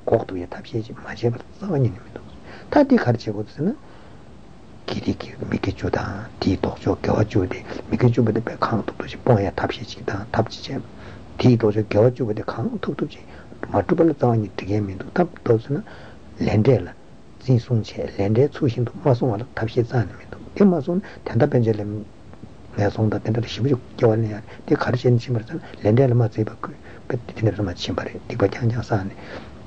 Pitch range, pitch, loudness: 105-130 Hz, 115 Hz, -22 LUFS